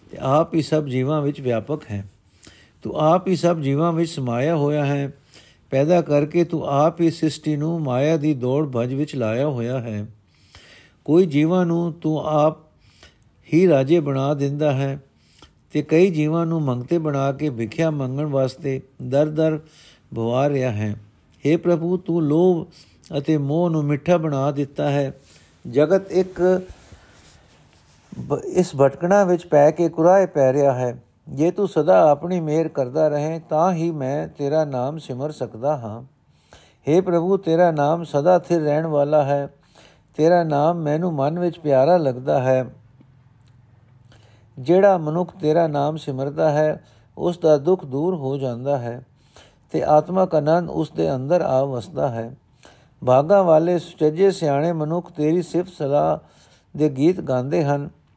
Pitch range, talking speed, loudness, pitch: 130-165 Hz, 150 wpm, -20 LUFS, 150 Hz